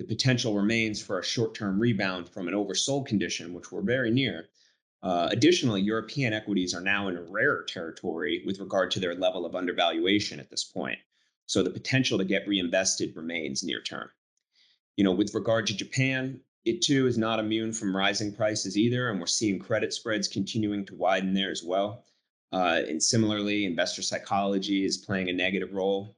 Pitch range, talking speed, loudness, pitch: 95-110 Hz, 185 wpm, -28 LUFS, 100 Hz